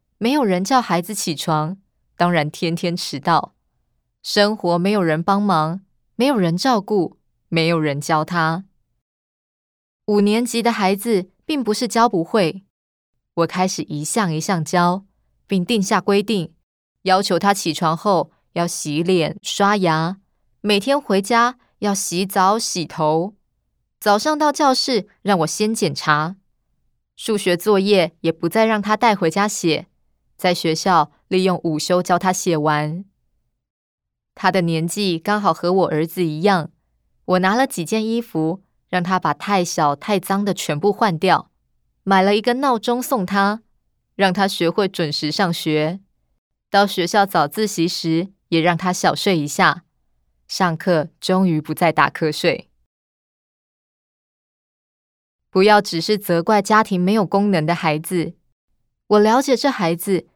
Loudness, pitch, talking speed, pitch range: -19 LUFS, 185 Hz, 200 characters per minute, 165-205 Hz